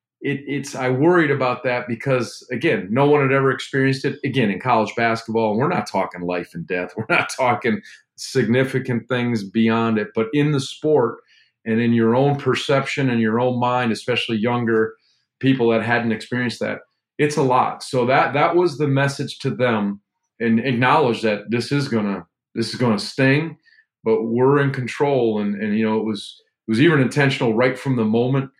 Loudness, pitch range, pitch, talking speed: -20 LUFS, 115-135 Hz, 125 Hz, 190 wpm